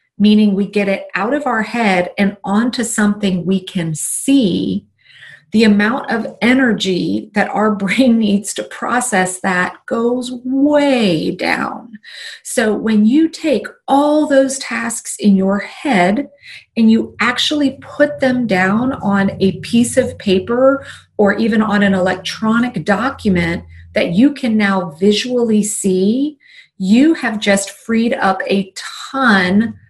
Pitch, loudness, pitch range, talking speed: 220 Hz, -15 LUFS, 195-255 Hz, 135 wpm